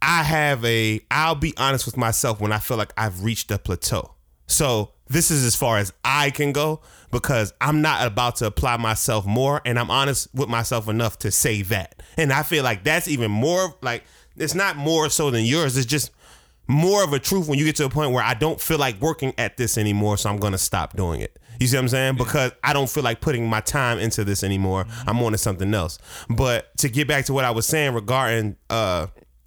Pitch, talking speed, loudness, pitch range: 125 Hz, 235 wpm, -21 LUFS, 110-145 Hz